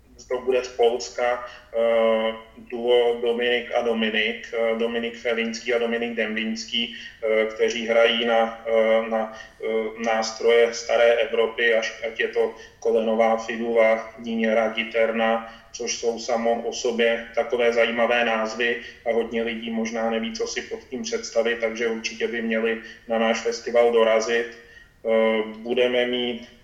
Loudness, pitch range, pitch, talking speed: -23 LUFS, 115-120 Hz, 115 Hz, 140 wpm